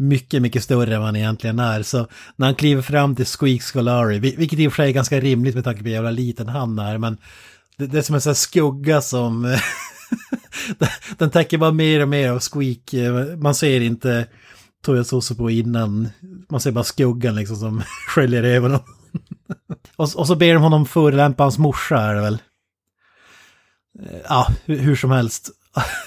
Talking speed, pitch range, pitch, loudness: 180 wpm, 115-145 Hz, 130 Hz, -19 LUFS